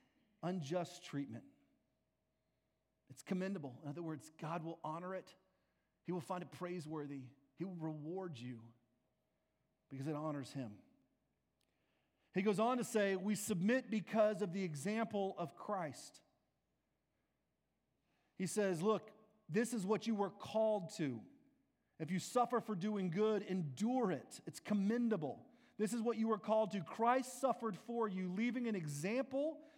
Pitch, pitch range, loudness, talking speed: 190 Hz, 160-220 Hz, -41 LUFS, 145 wpm